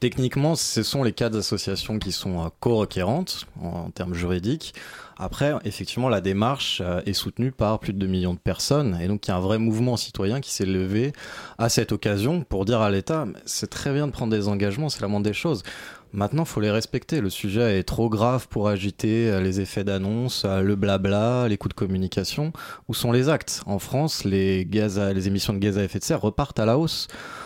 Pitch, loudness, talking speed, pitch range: 105 Hz, -24 LUFS, 210 wpm, 95-120 Hz